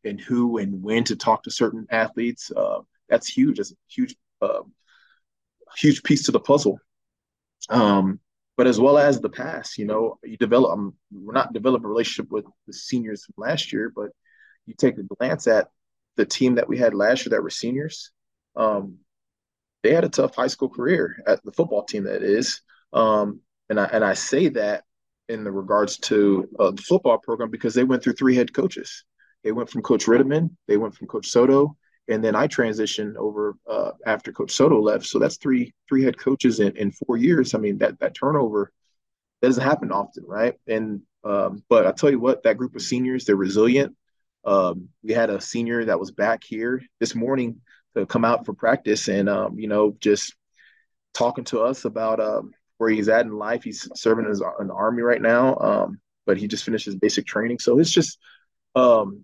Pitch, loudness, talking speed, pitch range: 120 Hz, -22 LUFS, 200 wpm, 105-140 Hz